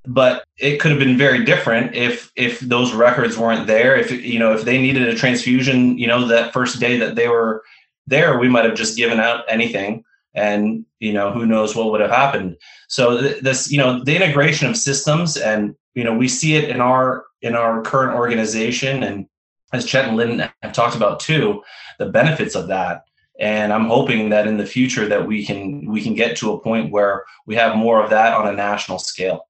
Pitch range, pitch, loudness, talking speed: 110-130 Hz, 120 Hz, -17 LUFS, 215 wpm